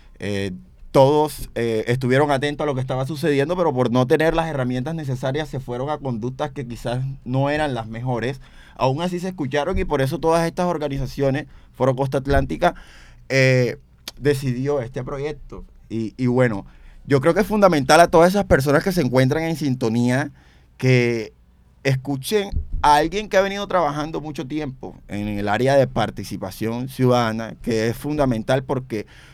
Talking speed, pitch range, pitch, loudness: 165 wpm, 120-150 Hz, 135 Hz, -21 LUFS